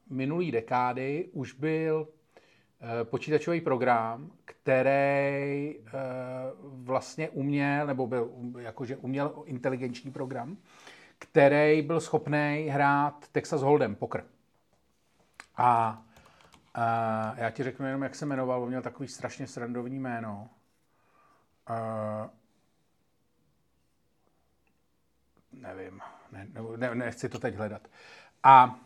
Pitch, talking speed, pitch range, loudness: 130 Hz, 105 wpm, 120-140 Hz, -29 LUFS